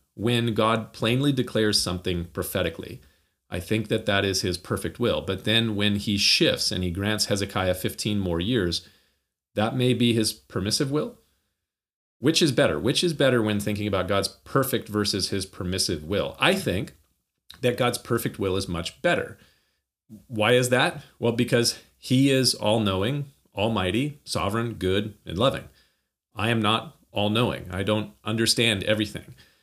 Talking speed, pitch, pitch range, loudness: 160 wpm, 105 Hz, 95-120 Hz, -24 LUFS